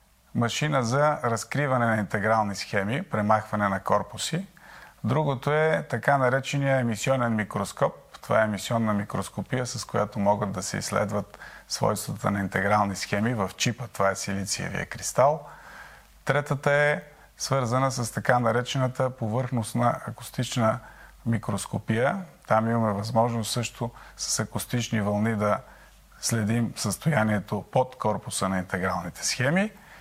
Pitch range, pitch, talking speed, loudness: 105-130 Hz, 115 Hz, 120 wpm, -26 LUFS